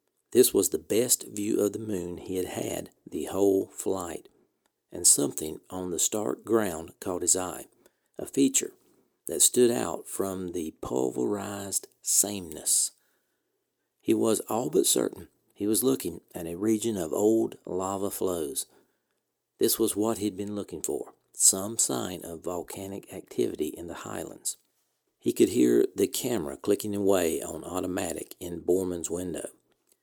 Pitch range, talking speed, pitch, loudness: 90-110 Hz, 150 wpm, 100 Hz, -27 LUFS